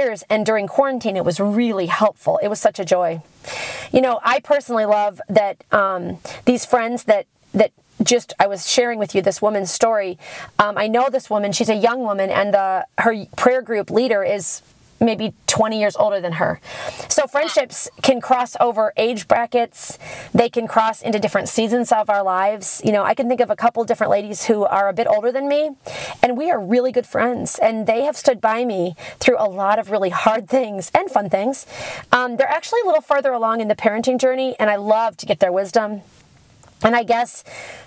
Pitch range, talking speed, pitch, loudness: 200-250 Hz, 205 wpm, 220 Hz, -18 LUFS